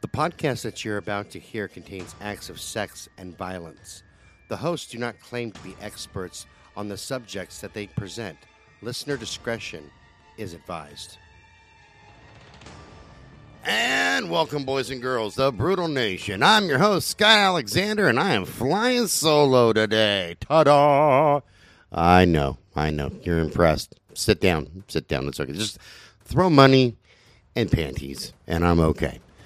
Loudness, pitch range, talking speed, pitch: -22 LUFS, 90-135 Hz, 145 wpm, 105 Hz